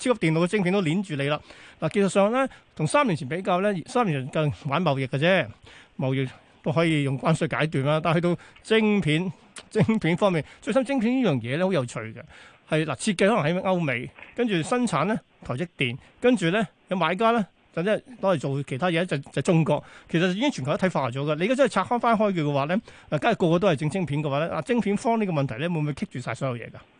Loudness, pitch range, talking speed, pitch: -25 LUFS, 145-205 Hz, 360 characters per minute, 170 Hz